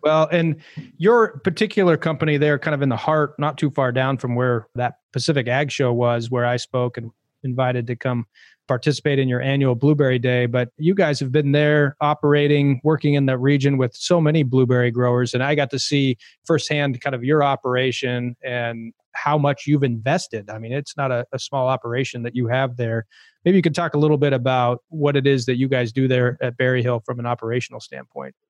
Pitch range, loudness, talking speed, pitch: 125-150 Hz, -20 LUFS, 215 wpm, 135 Hz